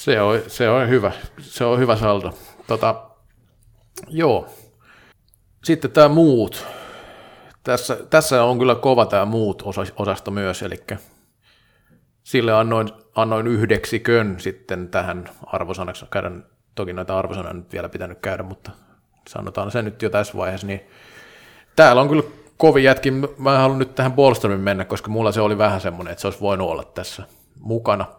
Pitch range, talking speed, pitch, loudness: 100-125 Hz, 150 wpm, 110 Hz, -19 LUFS